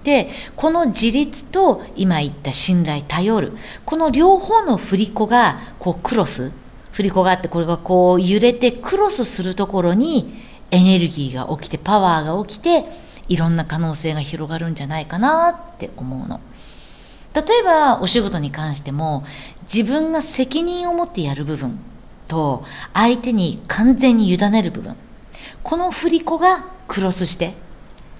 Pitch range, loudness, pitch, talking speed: 165-275 Hz, -18 LUFS, 200 Hz, 295 characters per minute